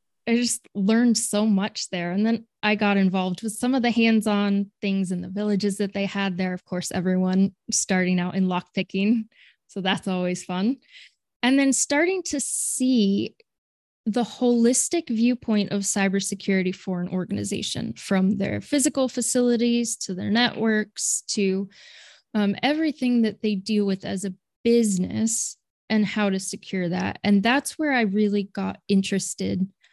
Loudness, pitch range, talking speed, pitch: -23 LUFS, 195-235 Hz, 155 wpm, 205 Hz